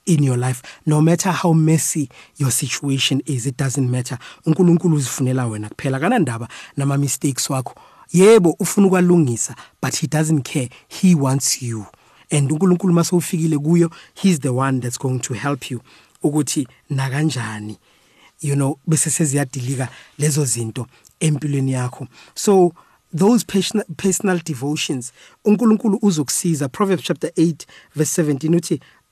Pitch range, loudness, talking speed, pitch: 135-170 Hz, -18 LUFS, 130 wpm, 150 Hz